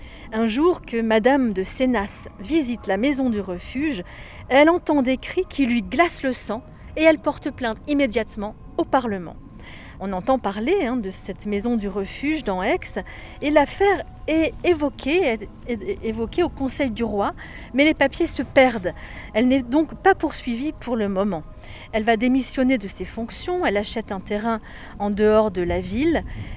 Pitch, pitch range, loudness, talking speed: 250 Hz, 210-295 Hz, -22 LUFS, 165 wpm